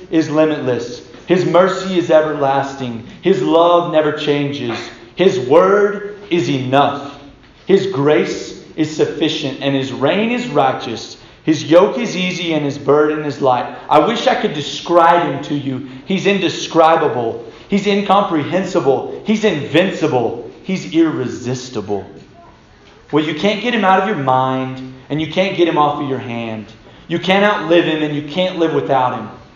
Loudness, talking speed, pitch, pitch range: -16 LUFS, 155 wpm, 155 Hz, 135-185 Hz